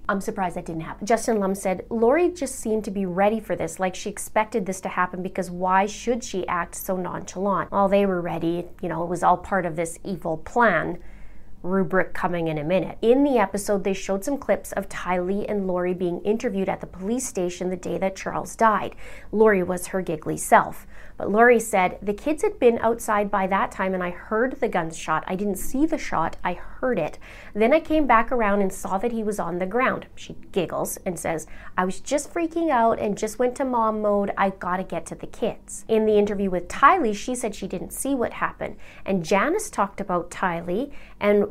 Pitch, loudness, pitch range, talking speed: 195 Hz, -24 LUFS, 180-225 Hz, 220 wpm